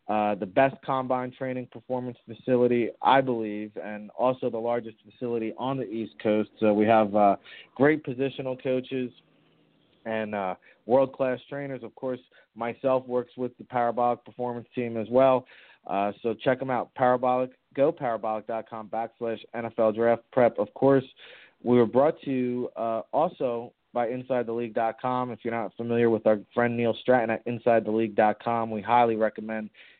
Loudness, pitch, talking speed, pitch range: -27 LUFS, 120 Hz, 155 wpm, 110-125 Hz